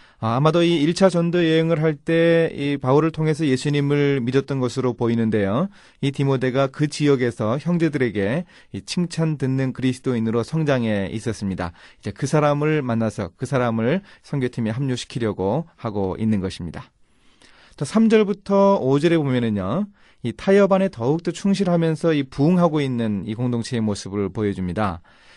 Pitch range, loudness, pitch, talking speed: 115-165 Hz, -21 LUFS, 135 Hz, 335 characters per minute